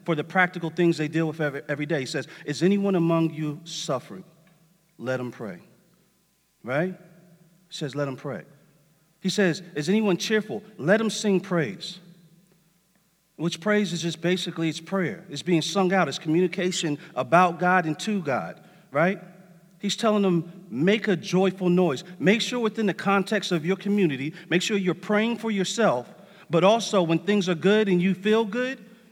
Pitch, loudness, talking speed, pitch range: 180 Hz, -25 LUFS, 175 wpm, 165-195 Hz